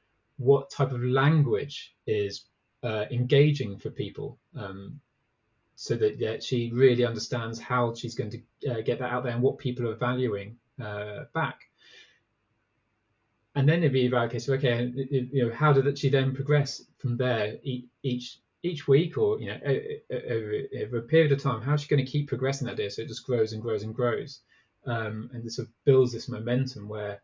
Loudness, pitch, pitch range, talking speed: -28 LUFS, 125 Hz, 115-135 Hz, 195 wpm